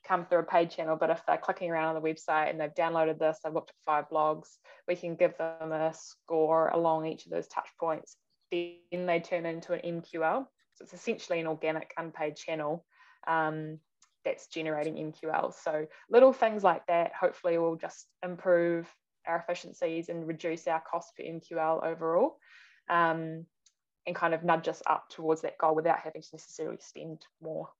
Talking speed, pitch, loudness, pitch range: 180 wpm, 165 Hz, -31 LUFS, 160-175 Hz